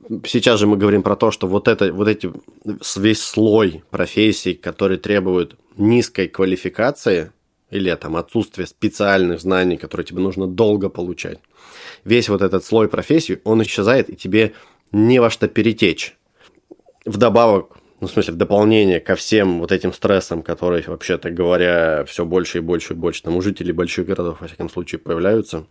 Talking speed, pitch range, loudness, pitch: 165 wpm, 90-105 Hz, -18 LUFS, 95 Hz